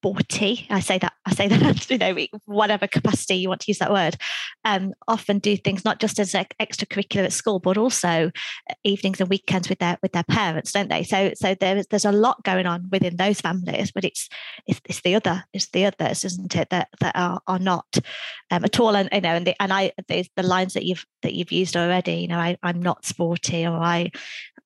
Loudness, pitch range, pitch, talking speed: -22 LUFS, 180-205 Hz, 190 Hz, 230 wpm